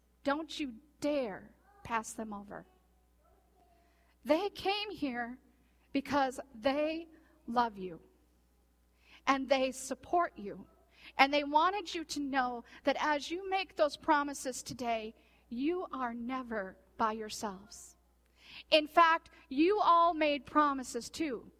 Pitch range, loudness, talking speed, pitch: 225-310 Hz, -33 LUFS, 115 wpm, 275 Hz